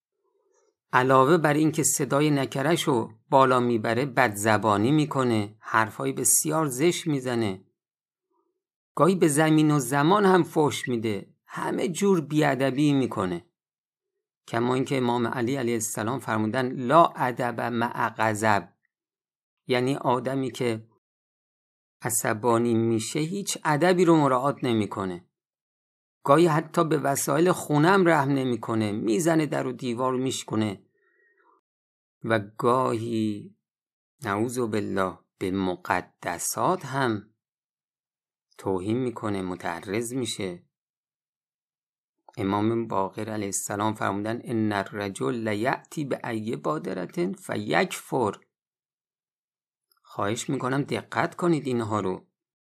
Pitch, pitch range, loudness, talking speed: 125 Hz, 110-150 Hz, -25 LUFS, 105 wpm